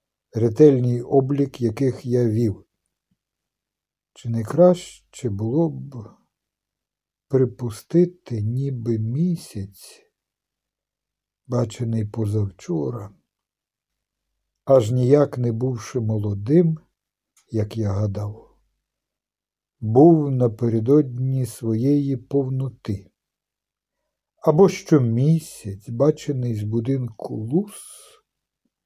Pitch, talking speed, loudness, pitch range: 125 Hz, 70 wpm, -21 LUFS, 110-140 Hz